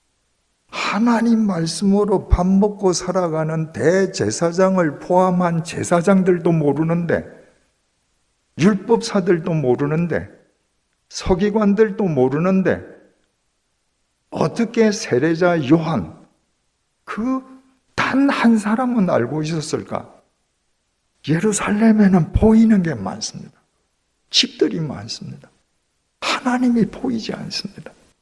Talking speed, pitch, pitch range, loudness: 215 characters per minute, 190 Hz, 165-215 Hz, -18 LUFS